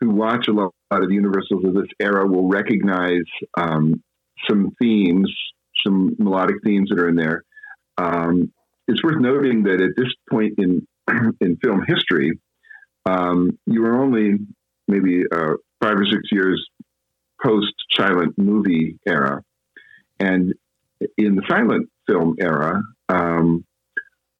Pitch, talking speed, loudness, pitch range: 100 Hz, 135 wpm, -19 LUFS, 90-110 Hz